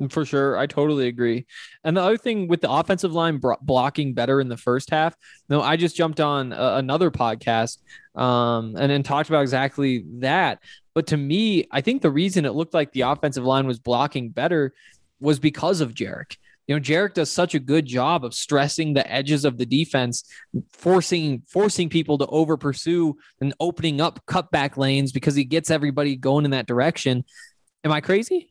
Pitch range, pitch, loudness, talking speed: 135-165 Hz, 145 Hz, -22 LUFS, 200 wpm